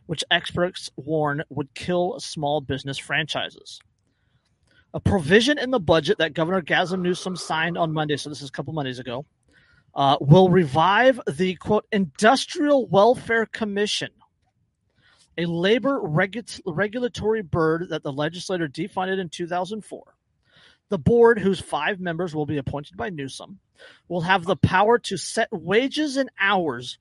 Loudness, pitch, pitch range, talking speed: -22 LUFS, 180 Hz, 155-205 Hz, 145 wpm